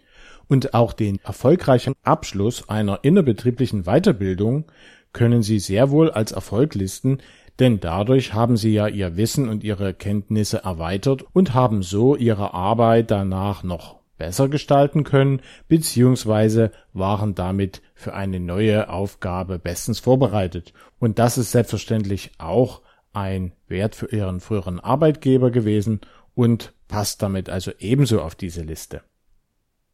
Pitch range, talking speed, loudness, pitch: 95-125 Hz, 130 wpm, -20 LUFS, 110 Hz